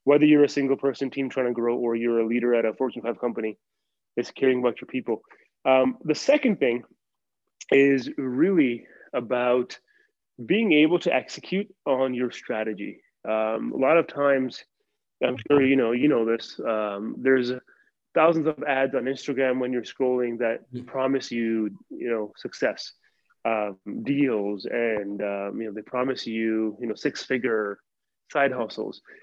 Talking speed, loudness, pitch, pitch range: 160 wpm, -25 LUFS, 125 Hz, 115-135 Hz